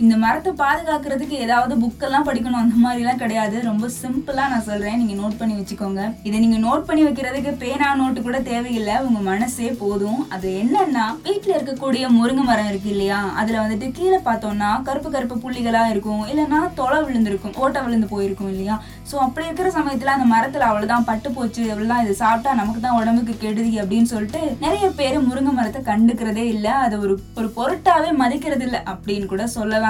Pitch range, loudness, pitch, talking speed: 215-270 Hz, -20 LUFS, 235 Hz, 170 wpm